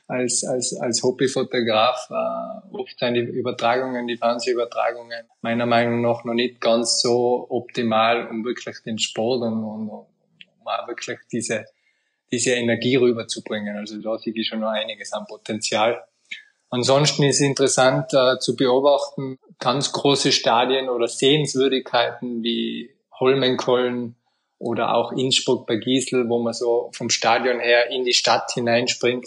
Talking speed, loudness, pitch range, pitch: 145 wpm, -21 LUFS, 115-130 Hz, 125 Hz